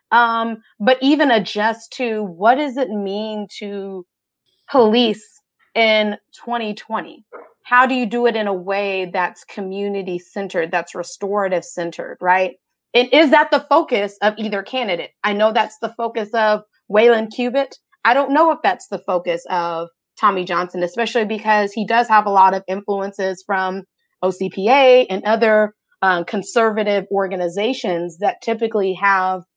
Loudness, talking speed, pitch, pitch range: -18 LUFS, 150 wpm, 210 Hz, 190-230 Hz